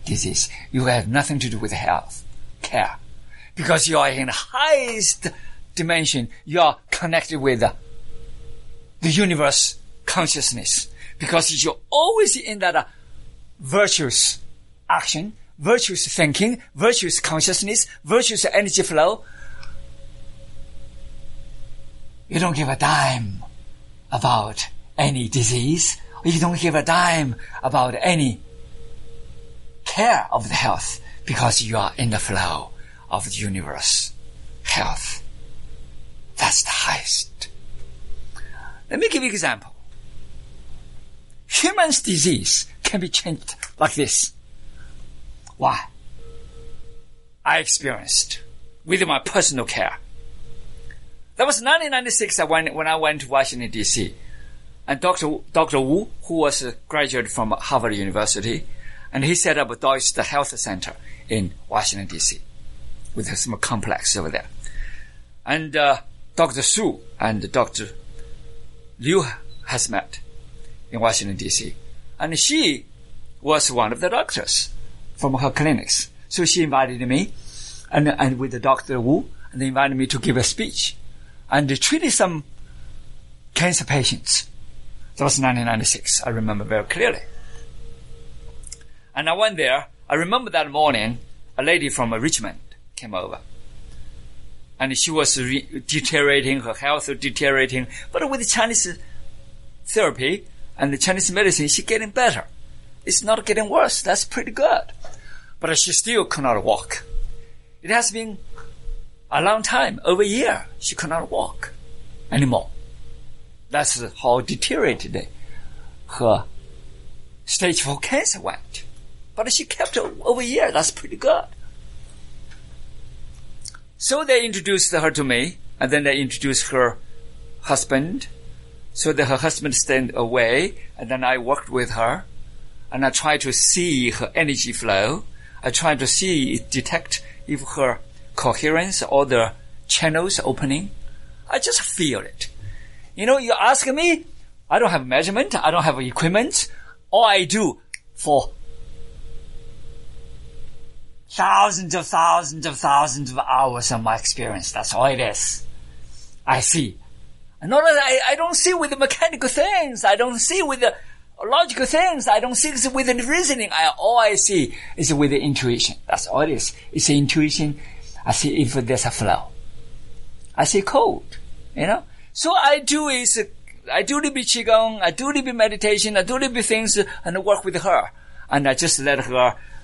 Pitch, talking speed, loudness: 140 Hz, 140 wpm, -20 LUFS